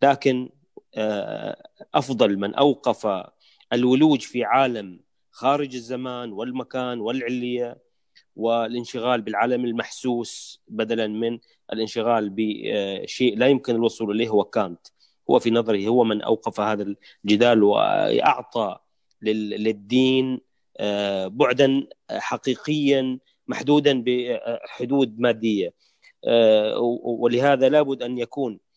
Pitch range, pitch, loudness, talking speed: 110-130 Hz, 120 Hz, -22 LUFS, 90 wpm